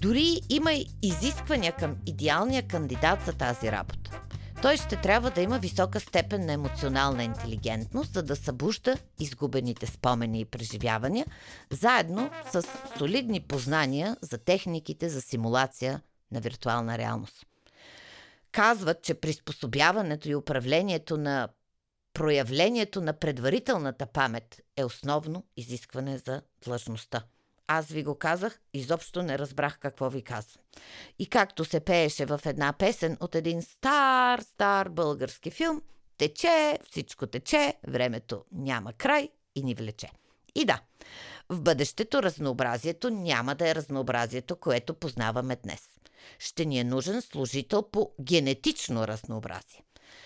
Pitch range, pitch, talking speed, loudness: 125-185 Hz, 145 Hz, 125 wpm, -29 LUFS